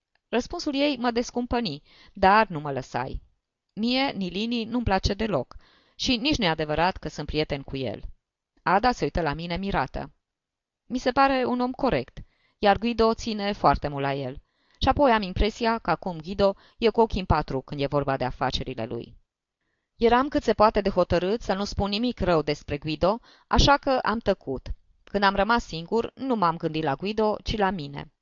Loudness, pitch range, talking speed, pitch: -25 LUFS, 155-235 Hz, 185 wpm, 200 Hz